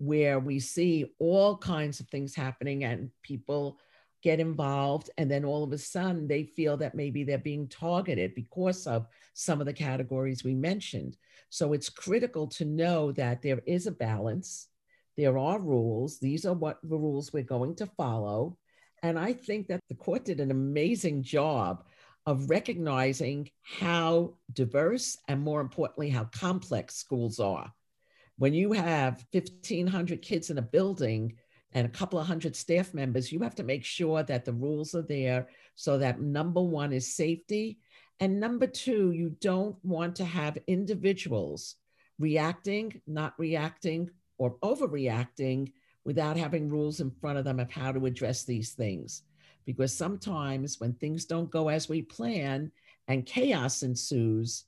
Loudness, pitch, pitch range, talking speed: -31 LUFS, 150 Hz, 130-175 Hz, 160 wpm